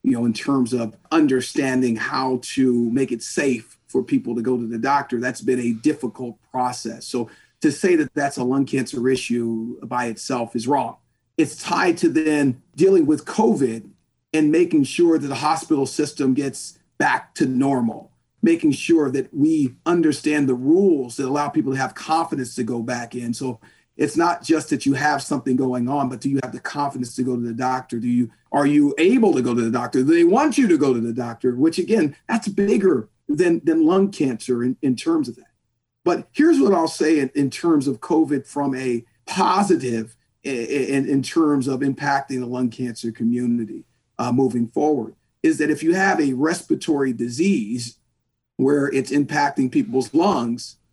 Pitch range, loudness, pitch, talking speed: 125-160 Hz, -21 LUFS, 135 Hz, 190 wpm